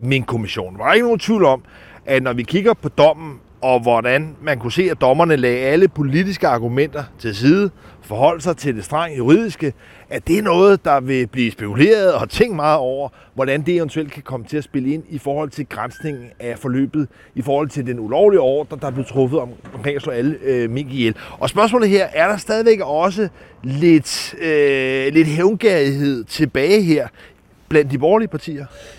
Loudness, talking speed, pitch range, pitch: -17 LUFS, 195 wpm, 125-165 Hz, 140 Hz